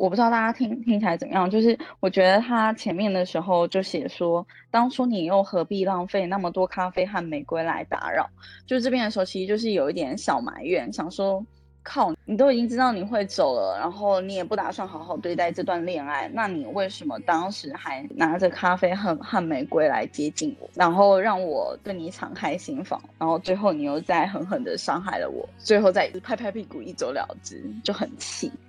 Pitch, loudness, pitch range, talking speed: 190 Hz, -25 LUFS, 180-220 Hz, 315 characters per minute